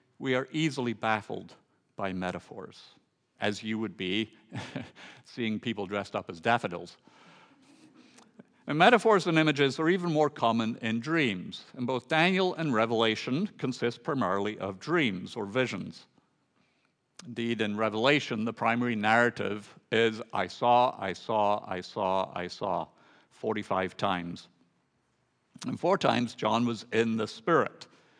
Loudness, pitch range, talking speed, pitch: -29 LUFS, 110-140 Hz, 130 wpm, 115 Hz